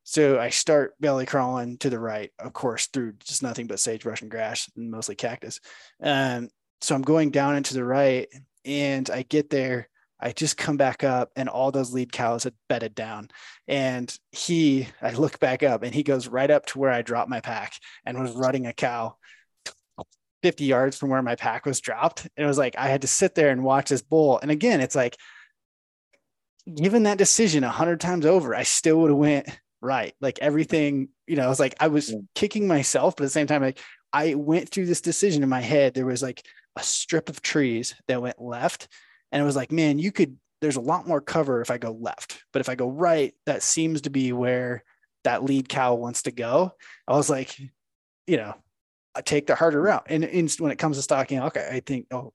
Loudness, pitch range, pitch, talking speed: -24 LUFS, 130-155 Hz, 140 Hz, 220 wpm